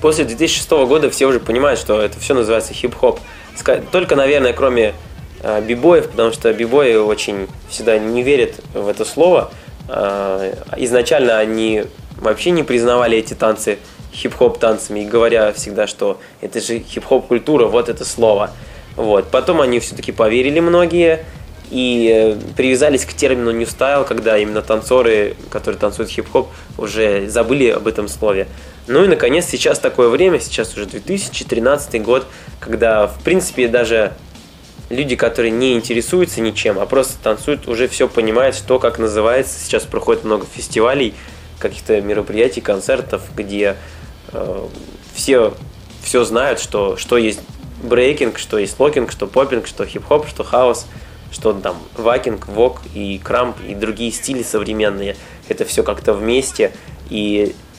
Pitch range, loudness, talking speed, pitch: 105-150 Hz, -16 LUFS, 140 wpm, 120 Hz